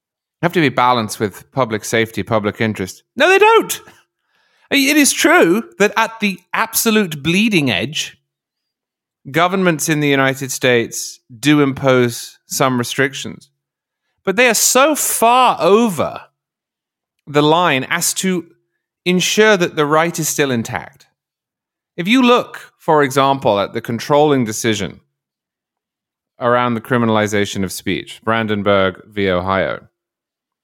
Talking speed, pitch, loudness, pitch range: 125 wpm, 140 Hz, -15 LUFS, 115-180 Hz